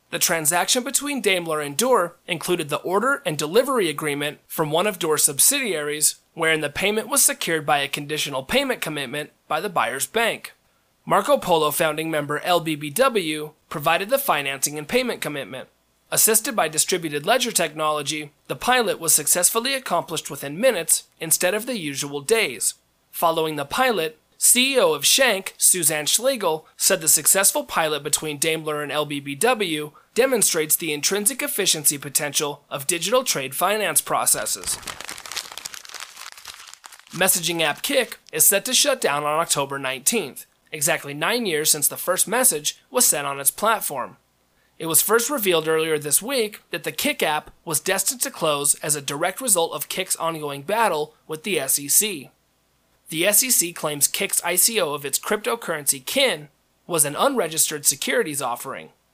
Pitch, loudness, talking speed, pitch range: 165 Hz, -20 LUFS, 150 wpm, 150-220 Hz